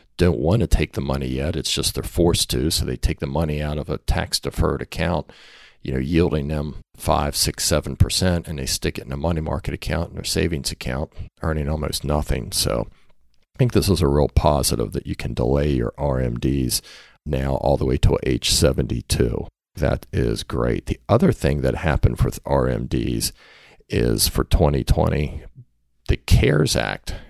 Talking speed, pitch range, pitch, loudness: 185 wpm, 70-85 Hz, 75 Hz, -22 LUFS